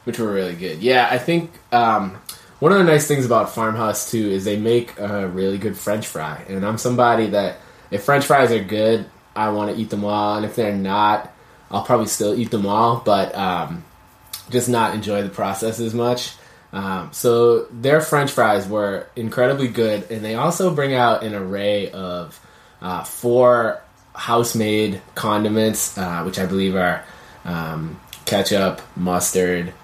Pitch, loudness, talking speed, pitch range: 110 Hz, -19 LUFS, 175 wpm, 100-120 Hz